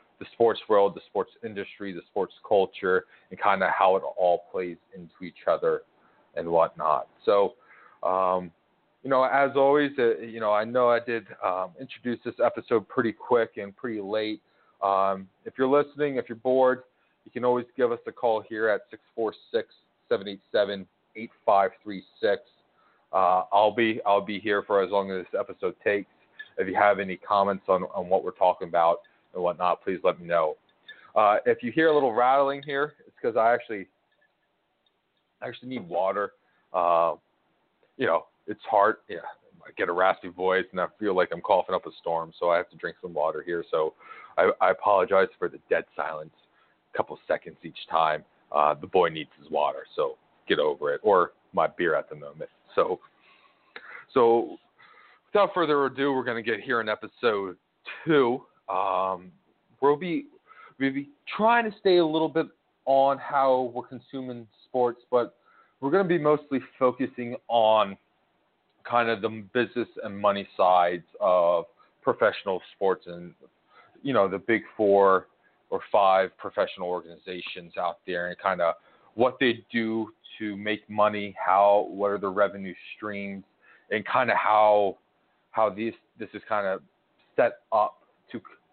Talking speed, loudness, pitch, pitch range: 170 wpm, -26 LUFS, 120 Hz, 100-160 Hz